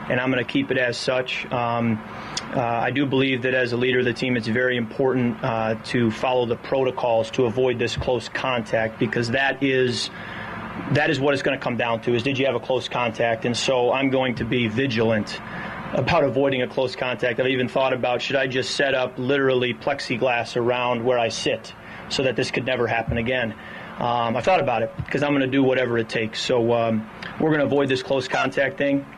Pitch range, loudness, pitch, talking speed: 120-130 Hz, -22 LUFS, 125 Hz, 225 wpm